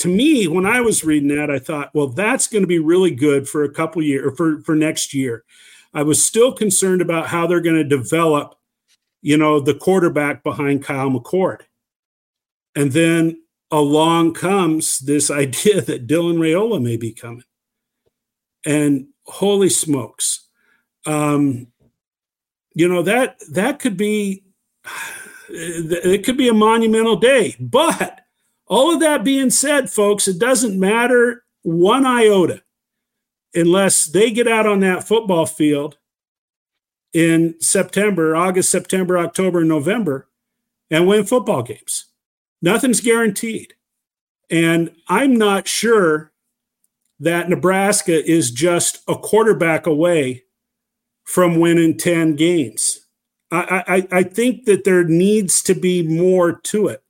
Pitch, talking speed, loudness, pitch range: 175 Hz, 135 wpm, -16 LUFS, 155-215 Hz